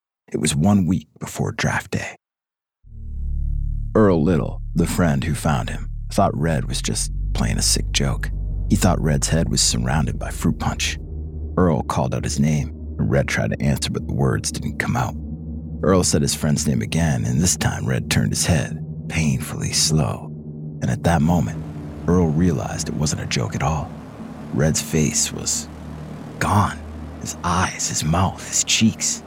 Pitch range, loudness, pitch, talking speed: 75-85 Hz, -21 LUFS, 75 Hz, 170 wpm